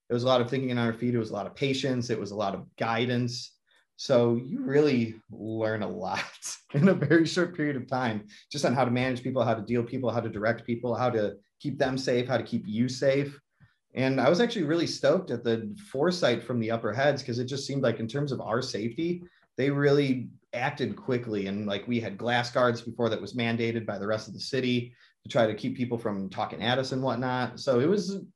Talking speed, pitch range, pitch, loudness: 245 wpm, 115-135 Hz, 120 Hz, -28 LUFS